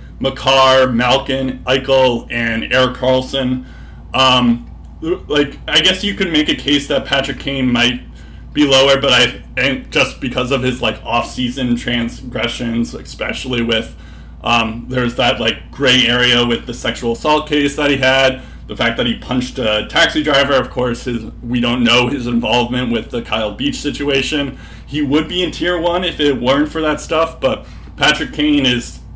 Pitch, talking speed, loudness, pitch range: 130 Hz, 175 wpm, -15 LUFS, 120-140 Hz